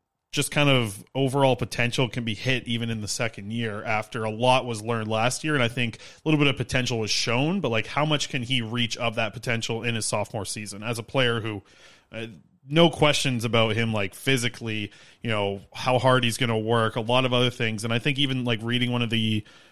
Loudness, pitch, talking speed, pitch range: -25 LUFS, 120 Hz, 235 wpm, 110-130 Hz